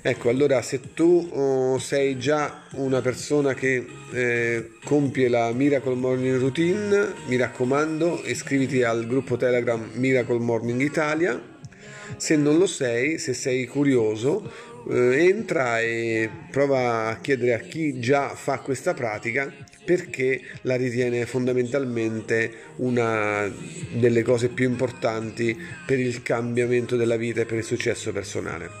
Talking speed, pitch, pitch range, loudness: 130 wpm, 125 Hz, 120-140 Hz, -24 LUFS